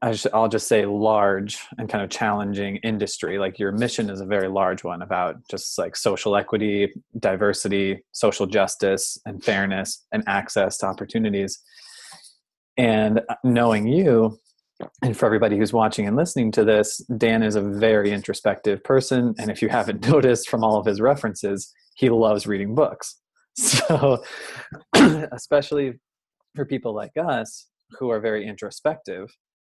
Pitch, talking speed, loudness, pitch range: 110 Hz, 145 wpm, -22 LUFS, 100-115 Hz